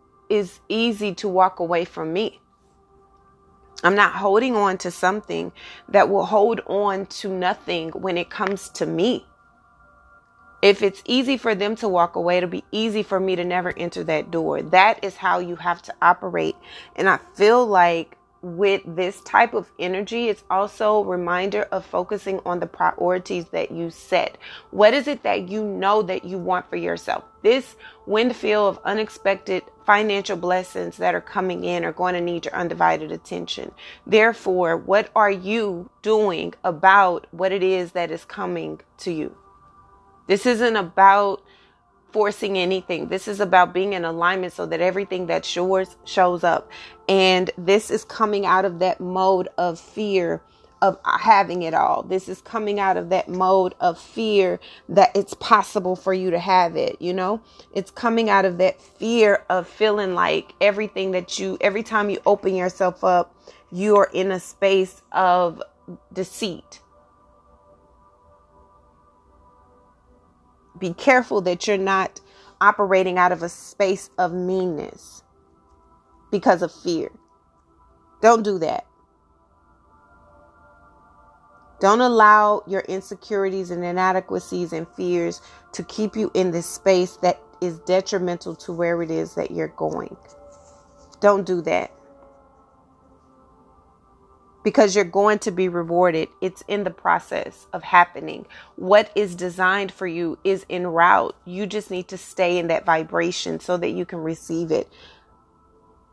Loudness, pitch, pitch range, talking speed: -21 LUFS, 185 Hz, 170-200 Hz, 150 wpm